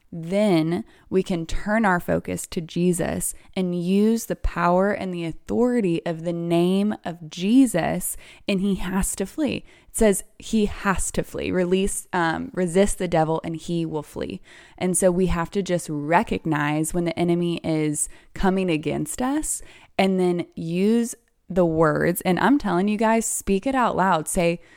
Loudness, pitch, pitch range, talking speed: -23 LUFS, 180 Hz, 170-200 Hz, 165 wpm